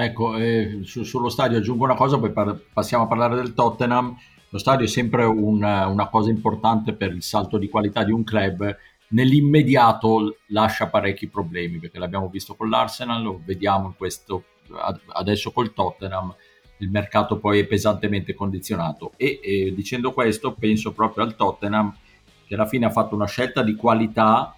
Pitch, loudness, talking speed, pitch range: 110 Hz, -22 LUFS, 170 wpm, 100-115 Hz